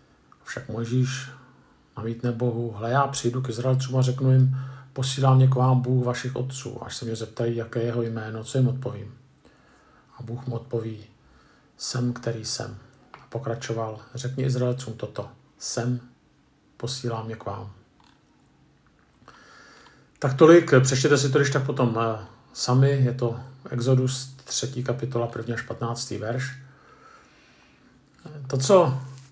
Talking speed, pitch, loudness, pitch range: 140 wpm, 125 Hz, -24 LUFS, 115-130 Hz